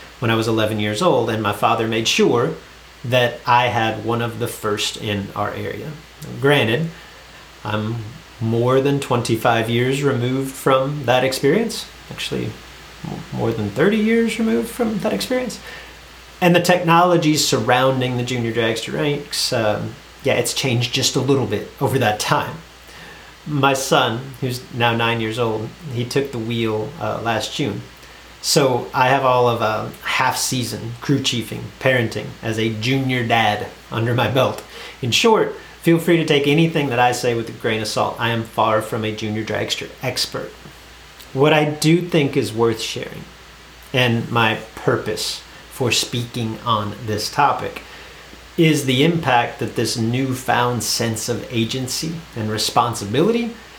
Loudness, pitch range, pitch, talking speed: -19 LUFS, 115-140 Hz, 120 Hz, 155 wpm